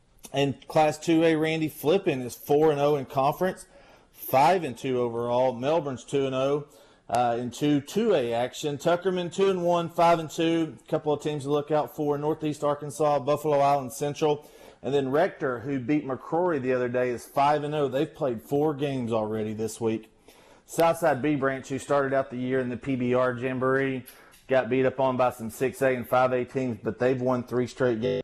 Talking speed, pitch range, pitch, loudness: 170 wpm, 125-150 Hz, 140 Hz, -26 LUFS